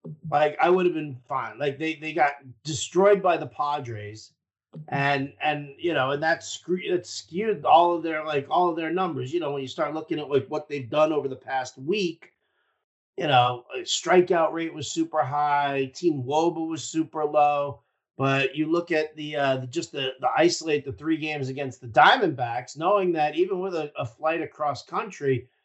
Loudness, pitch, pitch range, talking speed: -25 LUFS, 150 Hz, 140-165 Hz, 200 wpm